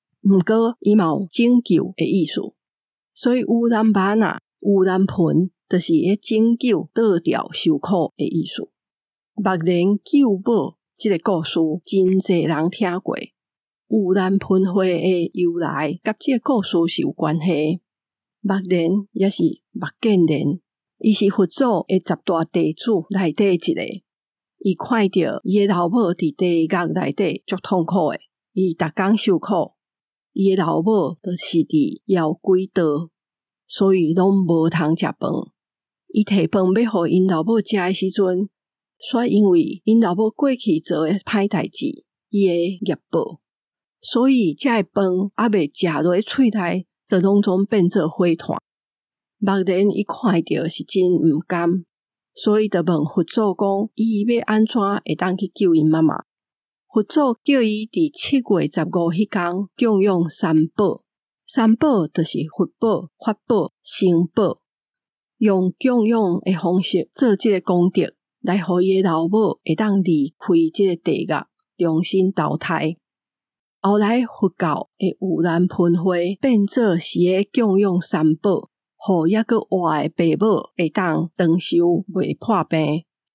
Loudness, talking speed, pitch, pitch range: -19 LUFS, 200 characters per minute, 190 Hz, 170-215 Hz